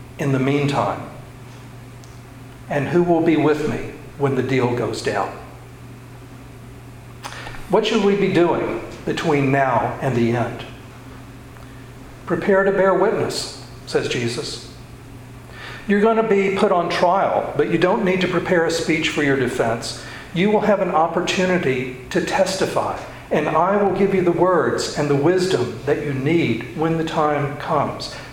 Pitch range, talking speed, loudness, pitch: 125-170 Hz, 155 wpm, -19 LUFS, 140 Hz